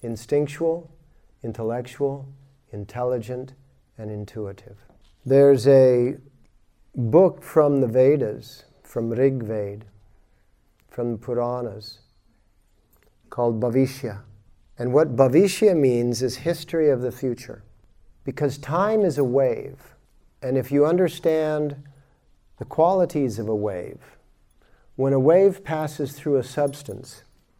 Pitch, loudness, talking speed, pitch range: 130 Hz, -22 LUFS, 105 wpm, 115-145 Hz